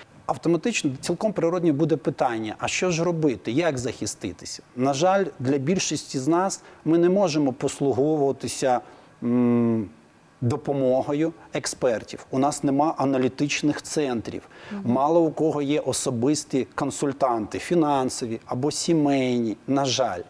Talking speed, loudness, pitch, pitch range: 115 wpm, -24 LUFS, 145 Hz, 130-165 Hz